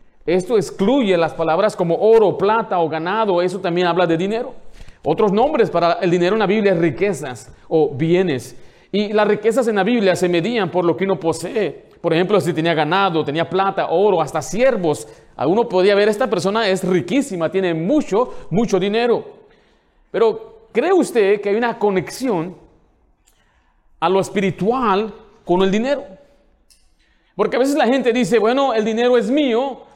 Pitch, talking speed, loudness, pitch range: 200 Hz, 170 wpm, -18 LUFS, 175-235 Hz